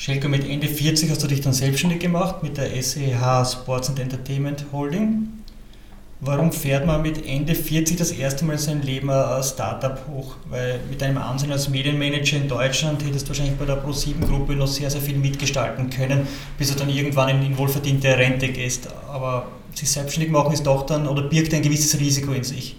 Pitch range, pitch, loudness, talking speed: 135-145 Hz, 140 Hz, -22 LUFS, 195 wpm